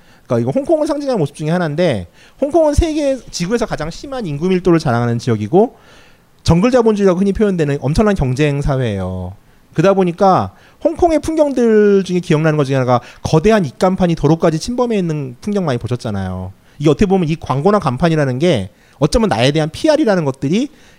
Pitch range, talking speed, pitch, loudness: 135-210 Hz, 415 characters per minute, 170 Hz, -15 LUFS